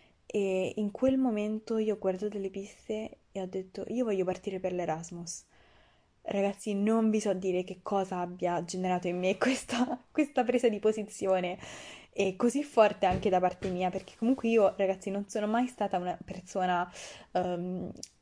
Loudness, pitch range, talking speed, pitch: -31 LUFS, 185-215 Hz, 170 wpm, 195 Hz